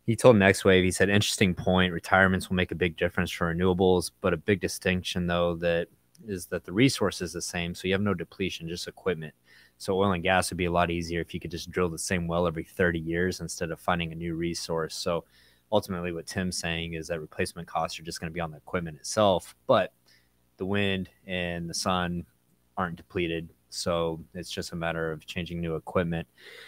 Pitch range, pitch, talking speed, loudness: 85-95 Hz, 85 Hz, 220 wpm, -28 LUFS